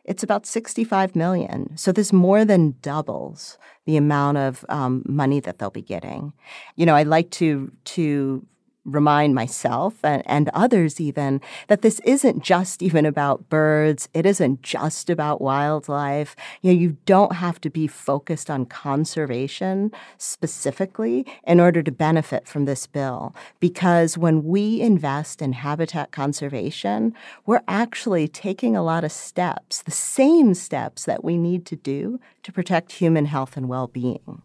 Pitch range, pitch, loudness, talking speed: 140-185 Hz, 160 Hz, -21 LUFS, 155 wpm